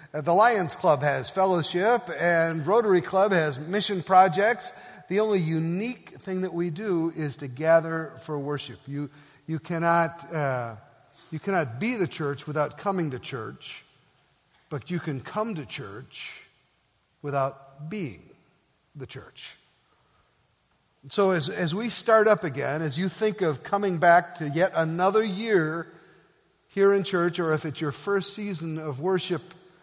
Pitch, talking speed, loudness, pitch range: 170 Hz, 150 wpm, -25 LUFS, 150-190 Hz